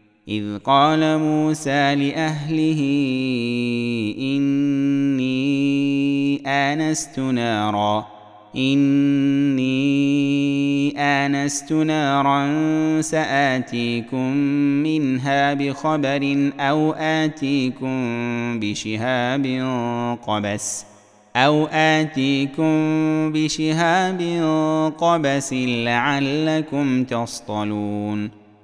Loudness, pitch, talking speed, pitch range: -20 LUFS, 140 Hz, 50 wpm, 120-150 Hz